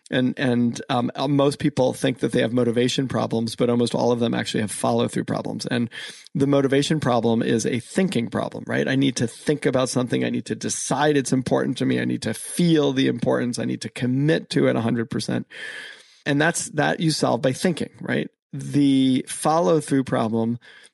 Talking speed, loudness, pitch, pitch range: 200 wpm, -22 LUFS, 130 Hz, 120-145 Hz